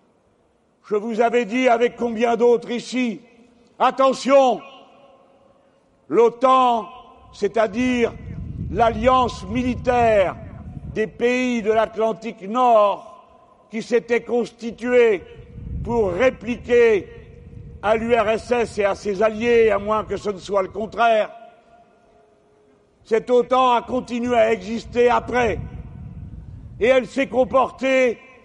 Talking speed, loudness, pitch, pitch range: 100 wpm, -20 LUFS, 240 Hz, 225-255 Hz